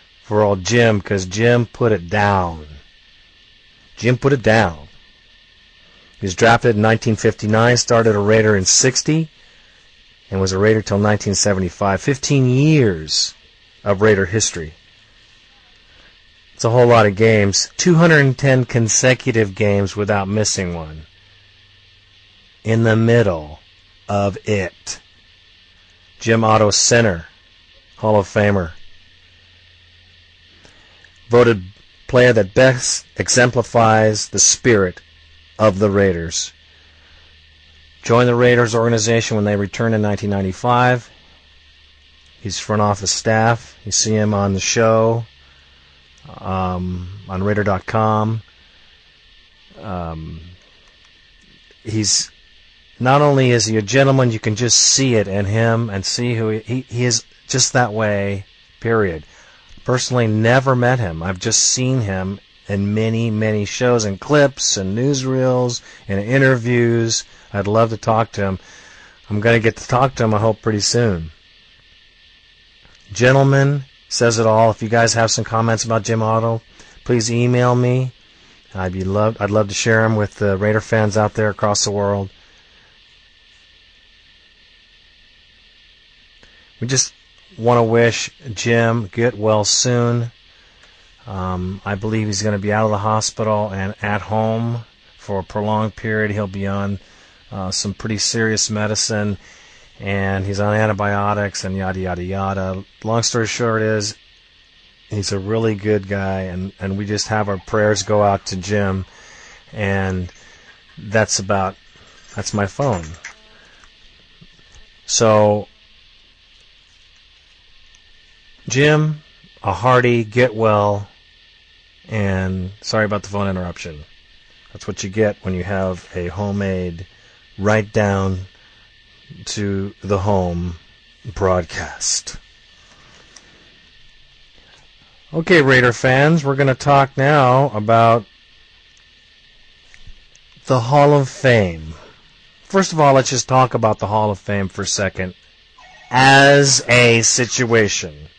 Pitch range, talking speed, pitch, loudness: 95-115 Hz, 125 wpm, 105 Hz, -16 LUFS